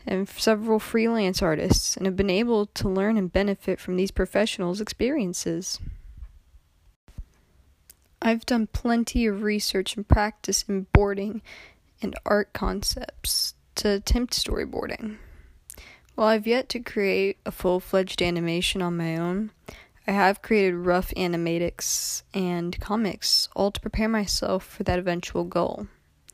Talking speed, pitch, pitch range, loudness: 130 wpm, 190 Hz, 170-215 Hz, -25 LUFS